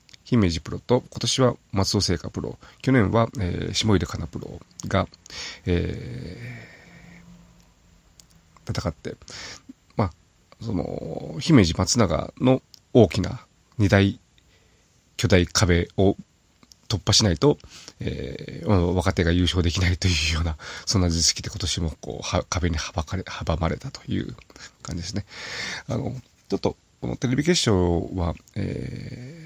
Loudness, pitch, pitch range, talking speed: -24 LUFS, 100 Hz, 90-125 Hz, 240 characters per minute